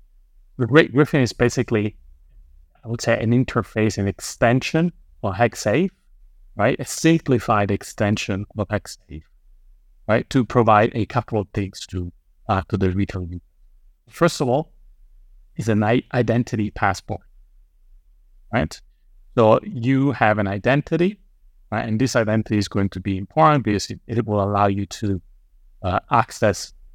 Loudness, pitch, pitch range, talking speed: -21 LUFS, 105 Hz, 90-120 Hz, 145 wpm